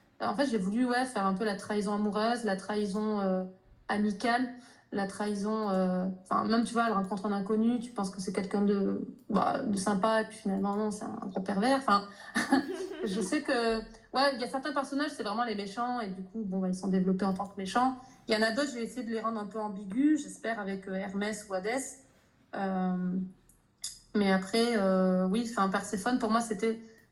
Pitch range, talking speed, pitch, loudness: 200-235 Hz, 220 wpm, 215 Hz, -31 LUFS